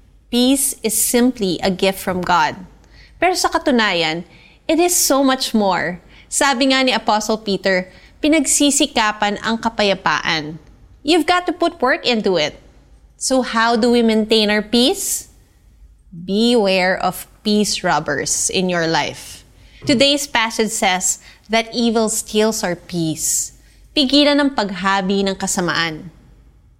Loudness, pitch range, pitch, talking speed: -17 LUFS, 185-260 Hz, 215 Hz, 130 wpm